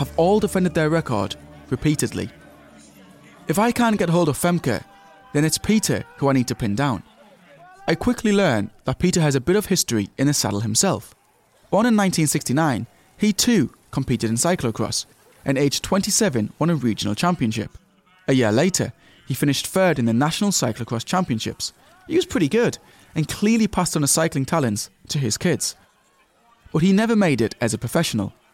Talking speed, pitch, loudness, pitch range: 175 wpm, 145 Hz, -21 LUFS, 115-185 Hz